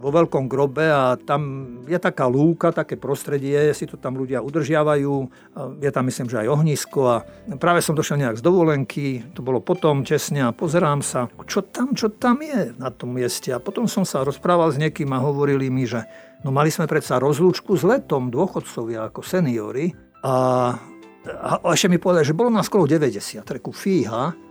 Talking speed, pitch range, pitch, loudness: 190 wpm, 130-170 Hz, 145 Hz, -21 LUFS